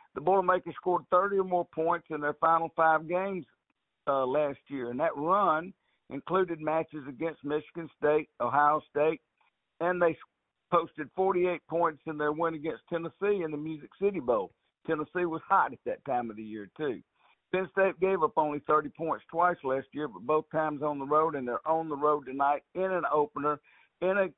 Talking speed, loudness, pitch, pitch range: 190 wpm, -30 LUFS, 160 Hz, 150-175 Hz